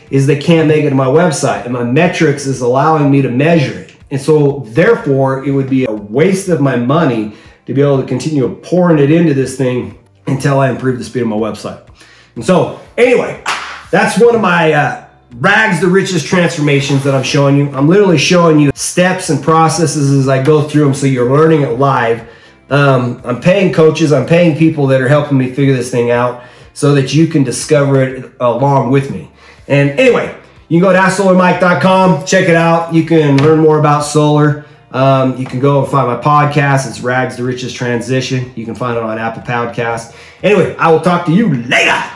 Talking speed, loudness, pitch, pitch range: 210 wpm, -11 LUFS, 140 Hz, 130-160 Hz